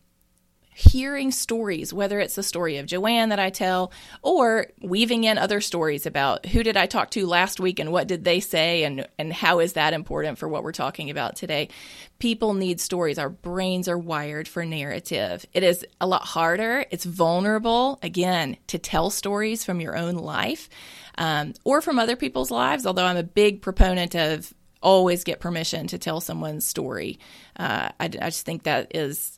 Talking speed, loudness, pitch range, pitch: 185 wpm, -24 LUFS, 165-205 Hz, 180 Hz